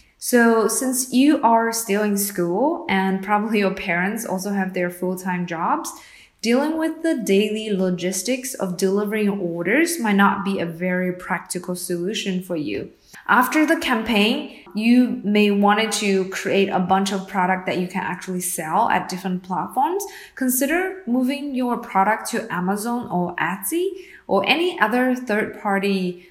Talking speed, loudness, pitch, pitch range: 150 wpm, -21 LUFS, 205 Hz, 185-250 Hz